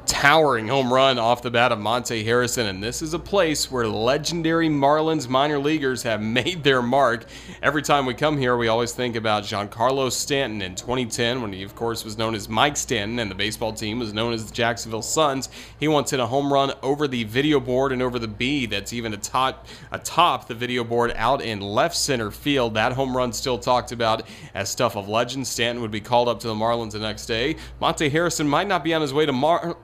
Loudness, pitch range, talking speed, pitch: -22 LUFS, 115-140 Hz, 225 wpm, 125 Hz